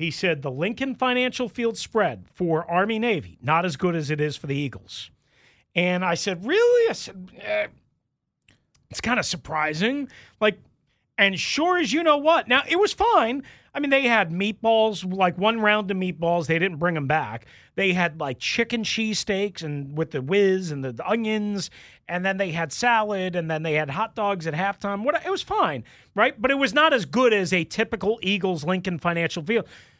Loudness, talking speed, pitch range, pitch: -23 LUFS, 200 wpm, 165-230 Hz, 195 Hz